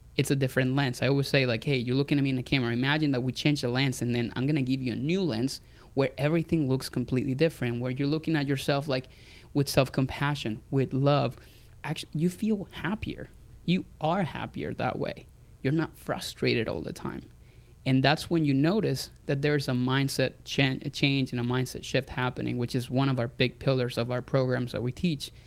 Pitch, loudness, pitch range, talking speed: 135 Hz, -28 LUFS, 125-145 Hz, 220 wpm